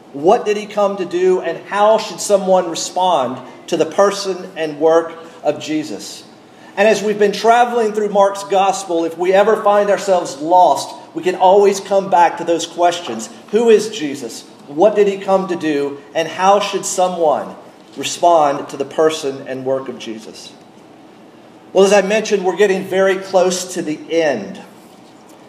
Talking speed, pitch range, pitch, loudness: 170 wpm, 160-200 Hz, 185 Hz, -15 LUFS